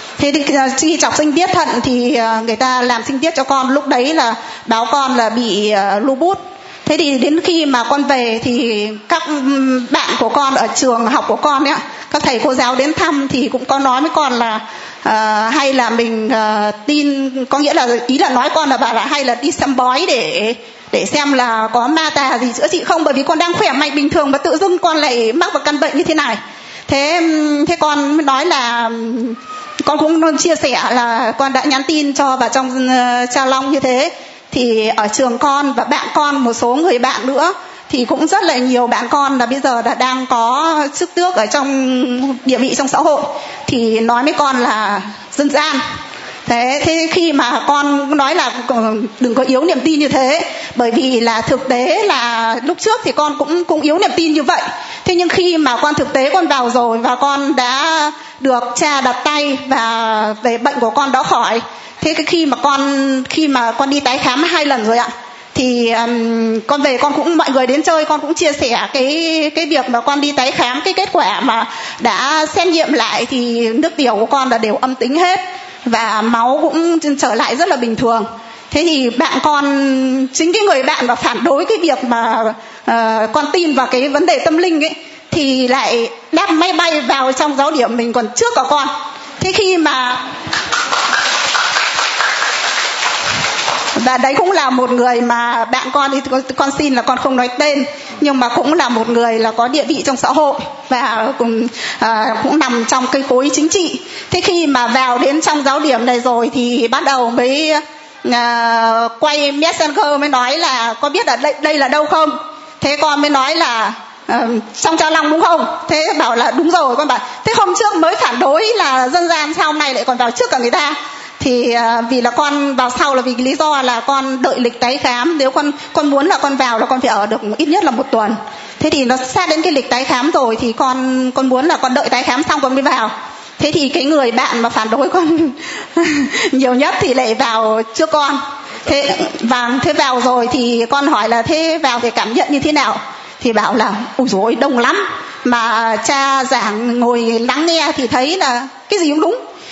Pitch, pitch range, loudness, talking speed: 275 Hz, 245-310 Hz, -13 LUFS, 215 wpm